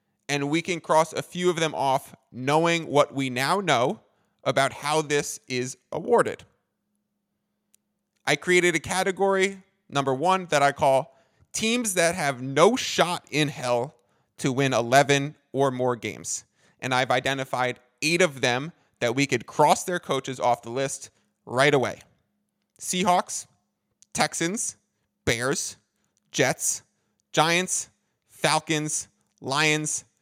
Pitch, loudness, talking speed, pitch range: 145 Hz, -24 LUFS, 130 wpm, 135-180 Hz